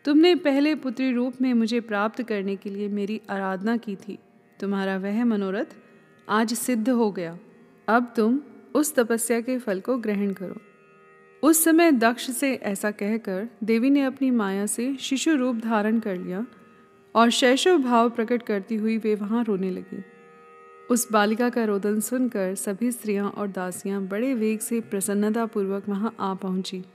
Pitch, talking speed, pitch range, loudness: 220 Hz, 160 wpm, 200-245 Hz, -24 LUFS